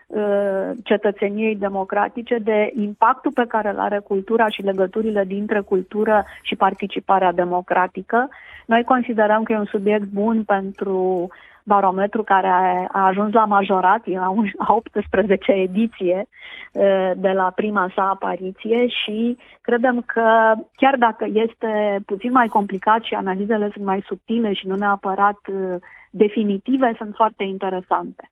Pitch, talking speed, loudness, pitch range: 205 Hz, 125 wpm, -20 LUFS, 195-225 Hz